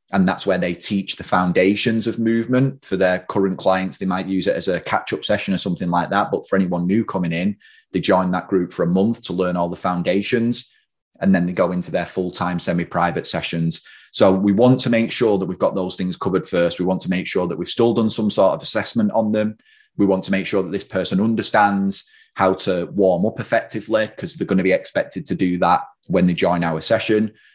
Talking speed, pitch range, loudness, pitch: 240 wpm, 90-110 Hz, -19 LUFS, 95 Hz